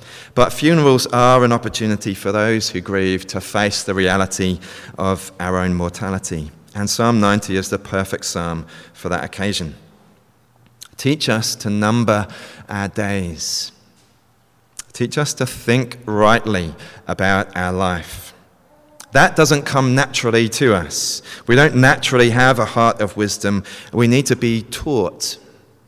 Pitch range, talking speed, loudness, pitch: 95-120 Hz, 140 wpm, -17 LUFS, 105 Hz